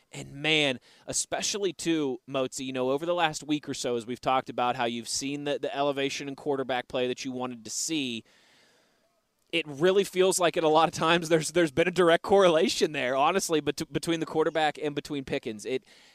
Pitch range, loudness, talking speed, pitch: 130-165 Hz, -27 LUFS, 210 wpm, 150 Hz